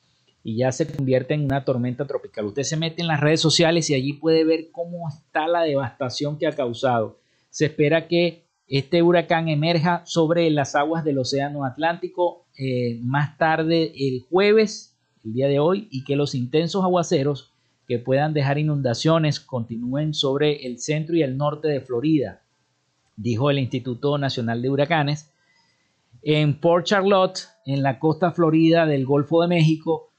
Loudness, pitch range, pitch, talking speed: -22 LUFS, 135-165 Hz, 150 Hz, 165 wpm